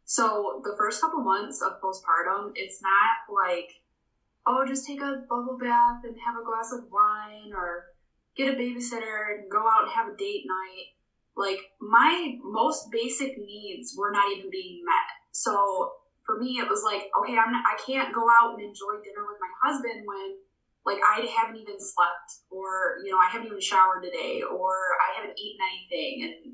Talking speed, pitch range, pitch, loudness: 190 wpm, 200-270 Hz, 230 Hz, -26 LUFS